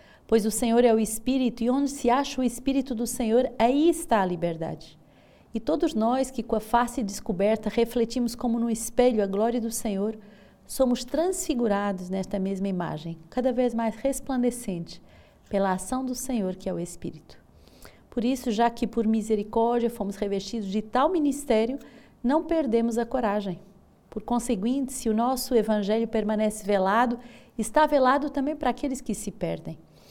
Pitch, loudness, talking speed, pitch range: 230 Hz, -26 LUFS, 165 wpm, 205-255 Hz